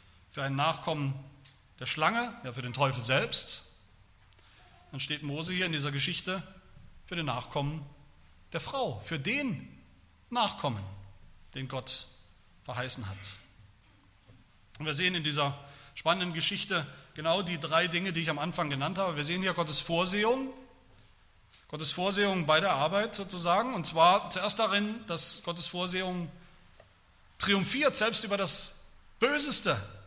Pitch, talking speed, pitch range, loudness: 155 Hz, 140 wpm, 125-180 Hz, -28 LUFS